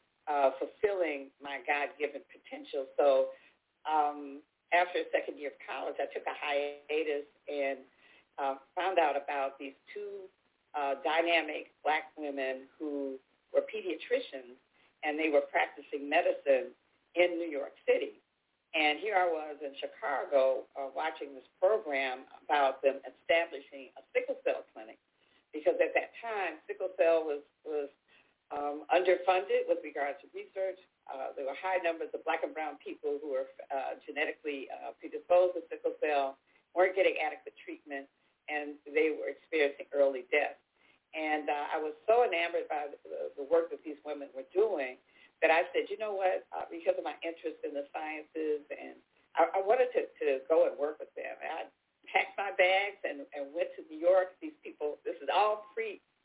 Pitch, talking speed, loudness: 175 Hz, 170 wpm, -33 LUFS